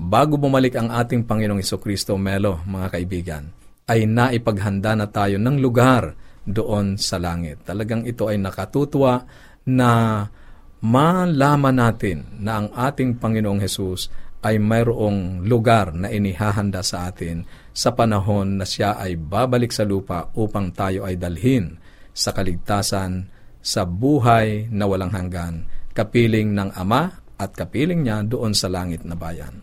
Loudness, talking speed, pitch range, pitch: -20 LUFS, 135 wpm, 95-115 Hz, 105 Hz